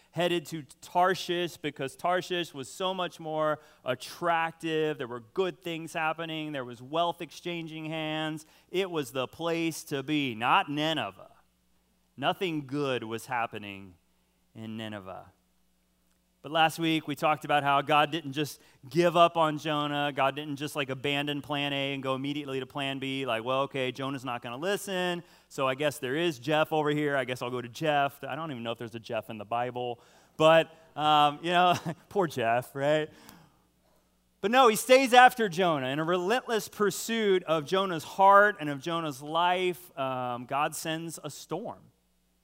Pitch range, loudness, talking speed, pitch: 130-165 Hz, -29 LUFS, 175 wpm, 150 Hz